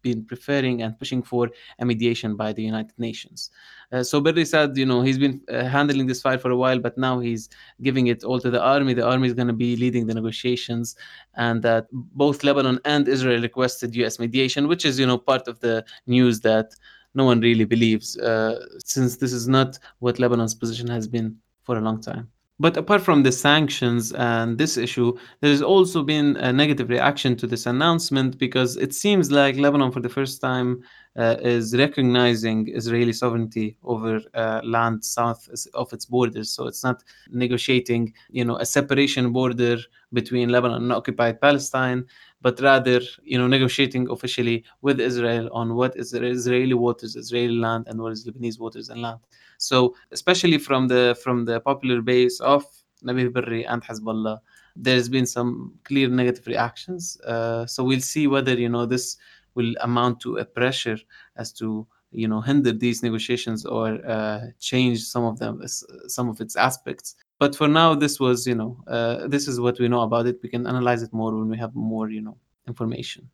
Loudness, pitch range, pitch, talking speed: -22 LUFS, 115-130 Hz, 125 Hz, 190 wpm